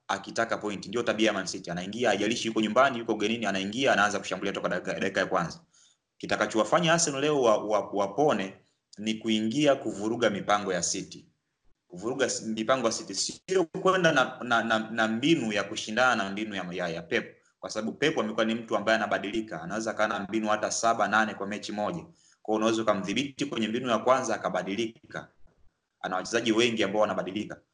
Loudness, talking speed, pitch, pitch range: -28 LUFS, 155 wpm, 110 Hz, 105-115 Hz